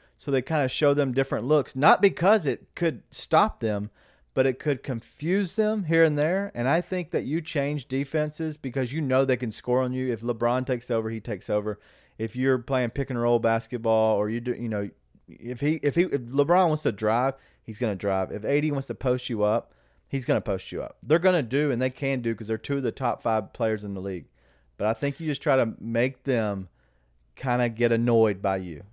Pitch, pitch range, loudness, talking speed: 125 Hz, 110-145 Hz, -26 LUFS, 240 wpm